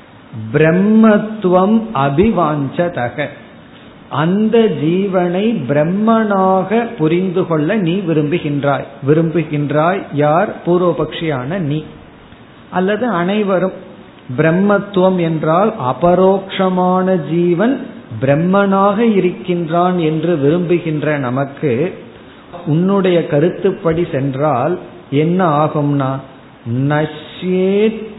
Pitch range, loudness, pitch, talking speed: 150-190 Hz, -15 LUFS, 175 Hz, 60 wpm